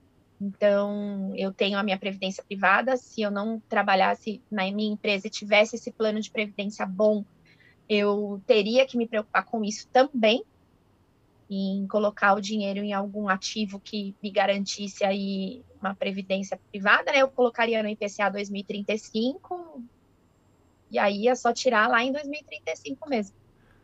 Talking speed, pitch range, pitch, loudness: 145 wpm, 195-225 Hz, 205 Hz, -26 LUFS